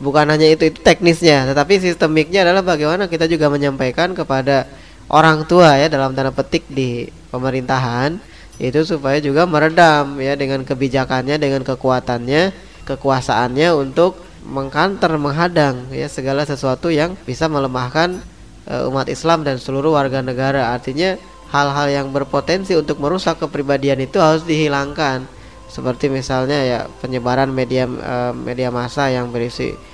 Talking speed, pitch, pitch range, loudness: 135 wpm, 140 Hz, 135-160 Hz, -16 LUFS